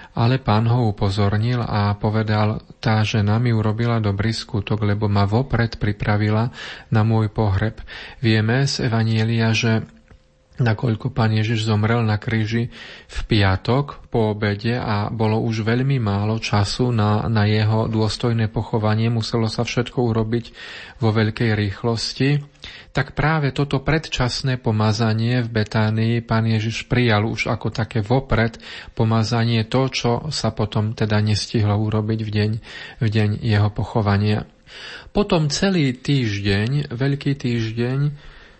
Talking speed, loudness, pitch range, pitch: 130 wpm, -20 LUFS, 110-120 Hz, 115 Hz